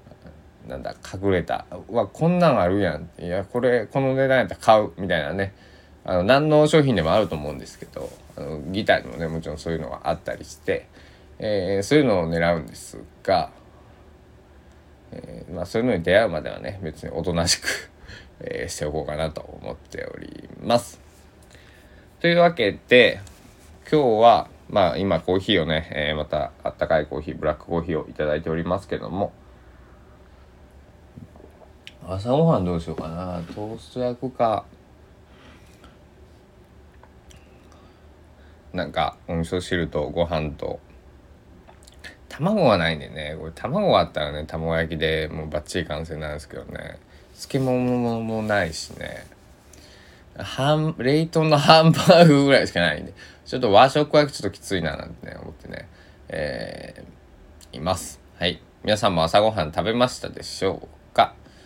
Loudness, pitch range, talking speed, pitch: -22 LUFS, 75-105 Hz, 310 characters per minute, 85 Hz